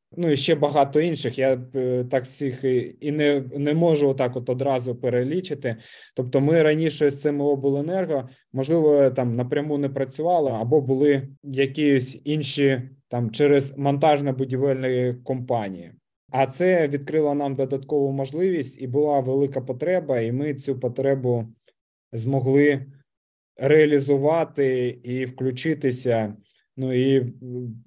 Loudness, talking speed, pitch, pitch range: -23 LUFS, 120 wpm, 135 Hz, 130-145 Hz